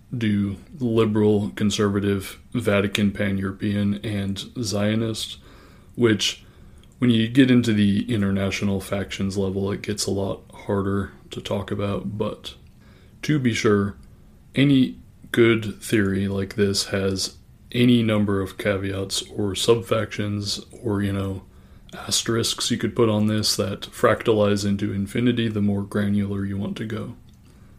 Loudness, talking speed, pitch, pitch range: -23 LUFS, 135 wpm, 100 Hz, 100-110 Hz